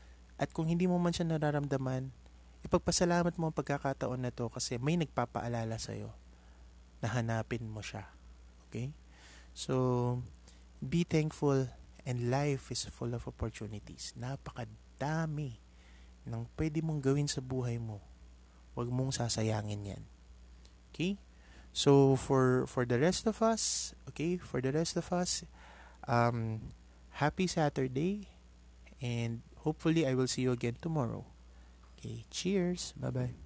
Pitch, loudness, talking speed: 120 Hz, -34 LUFS, 130 wpm